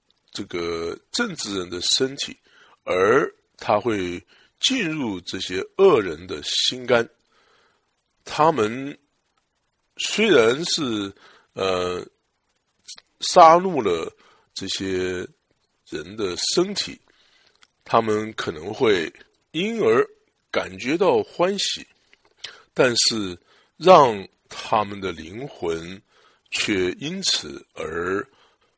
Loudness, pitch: -21 LUFS, 185 Hz